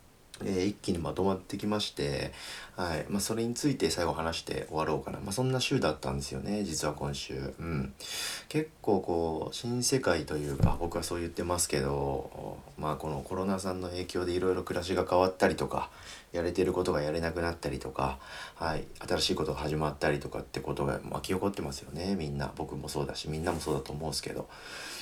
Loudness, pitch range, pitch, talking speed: -32 LUFS, 75-95 Hz, 85 Hz, 415 characters per minute